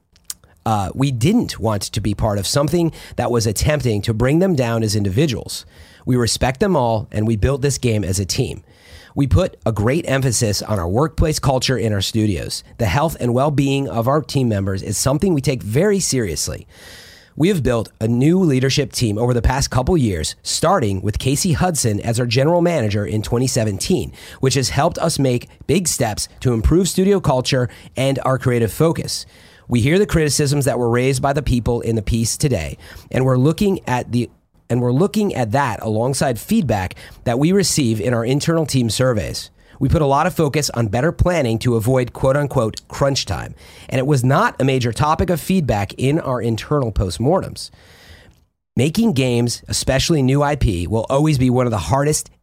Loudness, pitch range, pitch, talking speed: -18 LUFS, 110-145 Hz, 125 Hz, 190 wpm